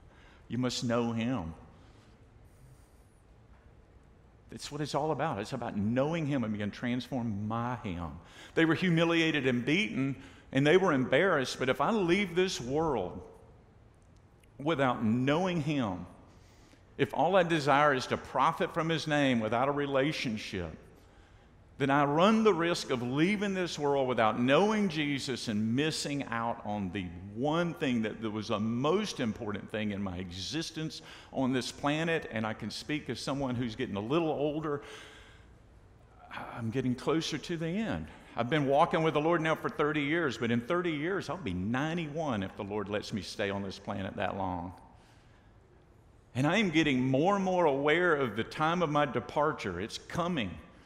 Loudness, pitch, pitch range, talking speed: -31 LUFS, 125 Hz, 110-155 Hz, 165 wpm